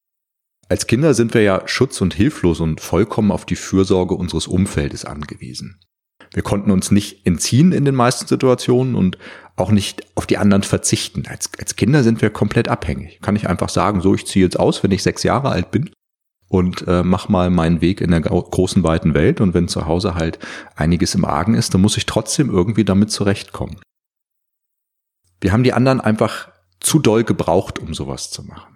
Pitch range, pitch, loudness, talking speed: 90-110 Hz, 100 Hz, -17 LUFS, 195 wpm